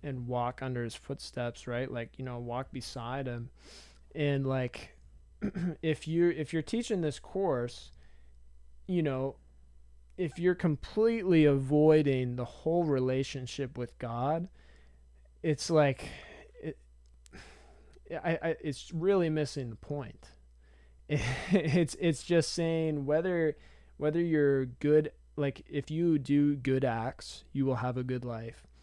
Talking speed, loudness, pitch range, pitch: 130 wpm, -31 LUFS, 120-155 Hz, 135 Hz